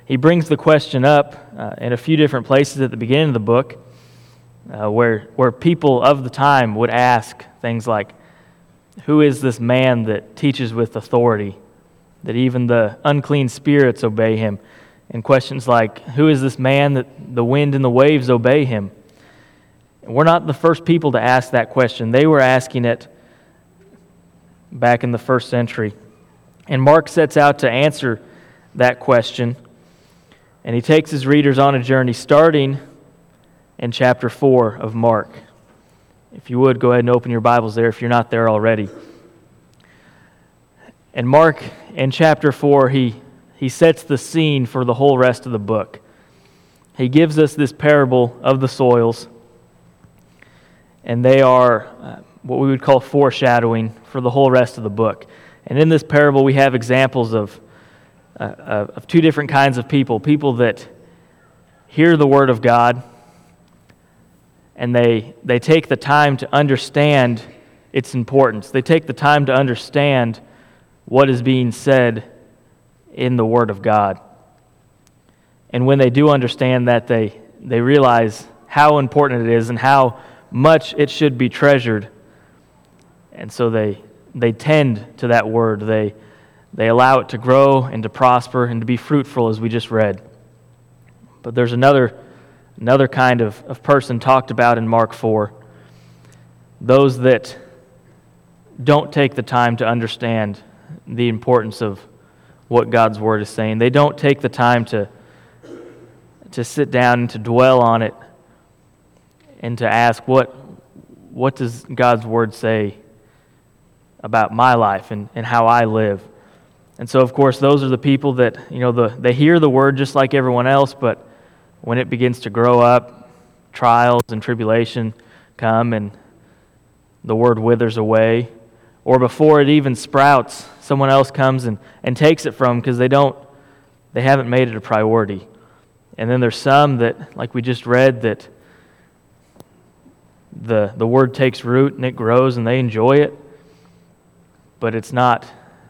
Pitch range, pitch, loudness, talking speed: 115-135 Hz, 125 Hz, -15 LUFS, 160 wpm